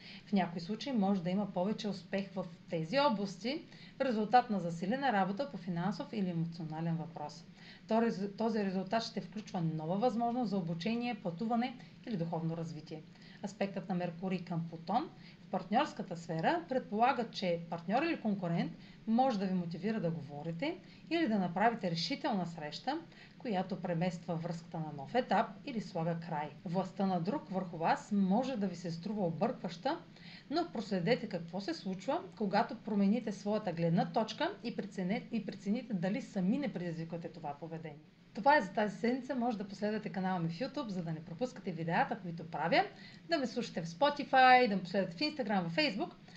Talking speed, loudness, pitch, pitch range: 165 wpm, -35 LUFS, 195 Hz, 175-230 Hz